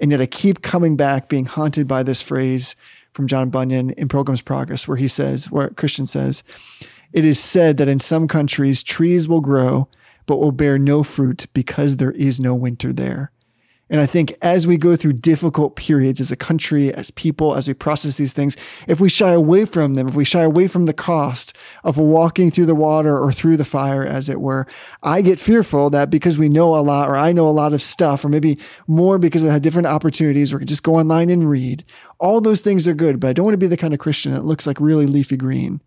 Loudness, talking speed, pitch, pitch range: -17 LUFS, 235 wpm, 150 Hz, 135-165 Hz